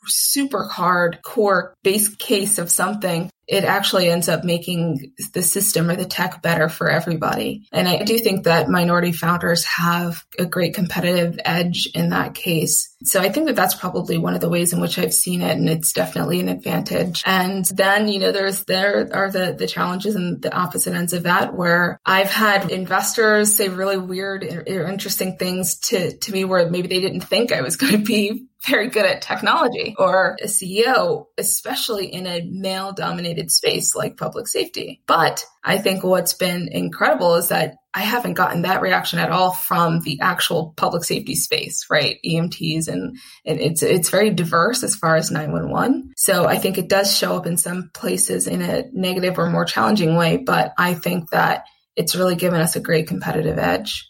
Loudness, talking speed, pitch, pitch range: -19 LUFS, 190 wpm, 180 Hz, 170-195 Hz